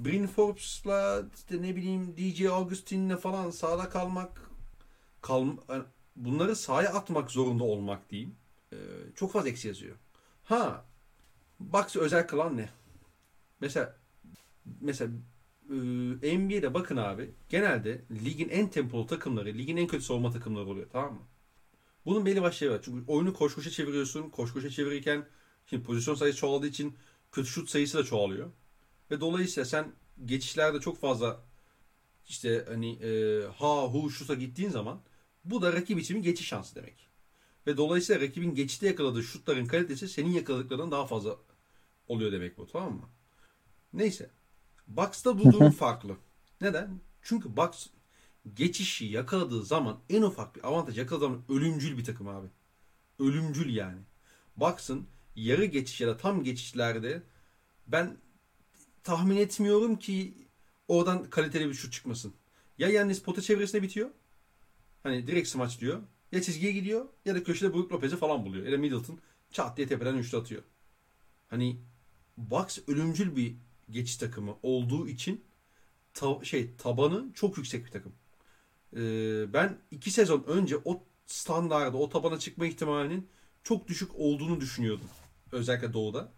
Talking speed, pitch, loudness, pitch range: 140 wpm, 145 Hz, -31 LUFS, 120-175 Hz